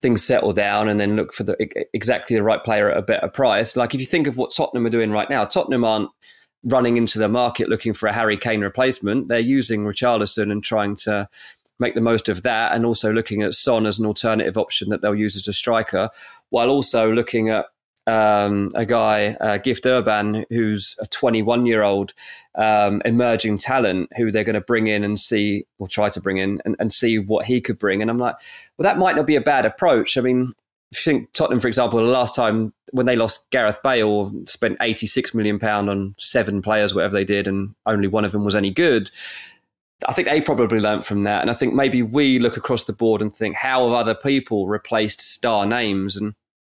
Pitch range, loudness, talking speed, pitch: 105-120 Hz, -19 LUFS, 225 wpm, 110 Hz